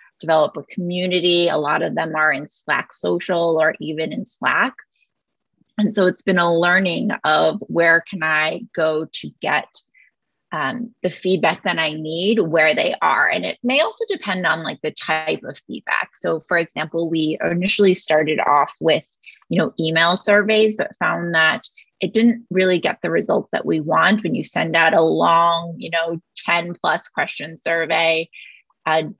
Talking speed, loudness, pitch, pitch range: 175 wpm, -19 LUFS, 170 Hz, 160-190 Hz